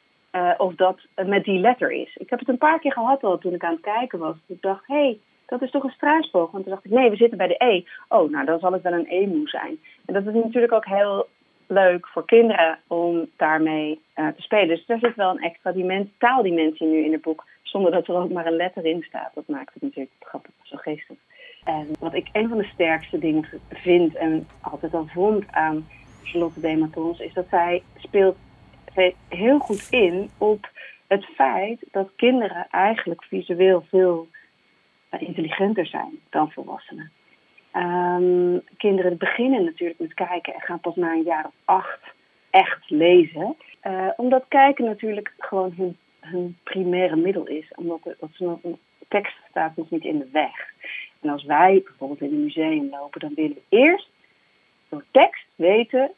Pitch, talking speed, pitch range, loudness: 185 Hz, 195 wpm, 165-230 Hz, -22 LUFS